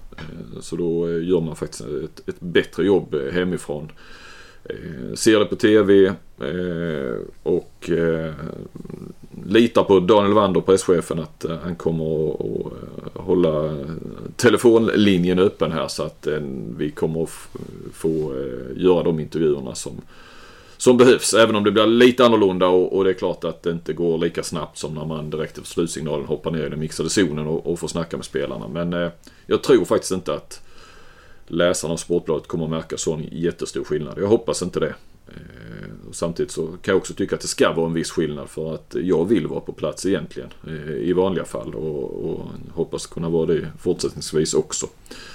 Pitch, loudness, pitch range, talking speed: 85 Hz, -21 LUFS, 80-95 Hz, 165 wpm